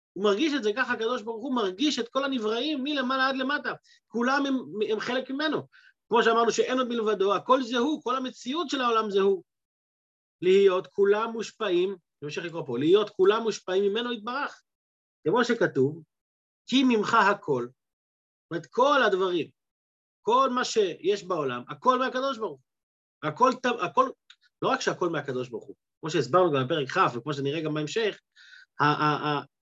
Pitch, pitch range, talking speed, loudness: 230 Hz, 180-265 Hz, 160 wpm, -26 LUFS